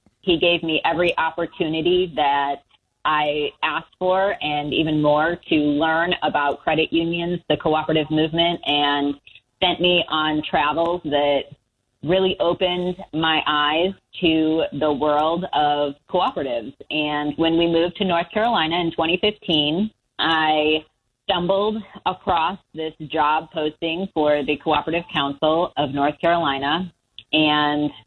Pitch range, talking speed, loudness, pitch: 150-170 Hz, 125 wpm, -21 LUFS, 155 Hz